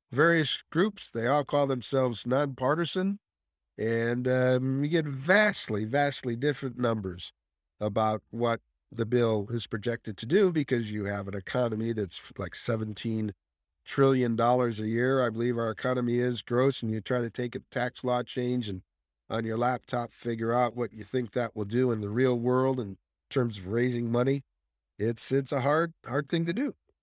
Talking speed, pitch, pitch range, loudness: 175 wpm, 120 Hz, 110-130 Hz, -29 LUFS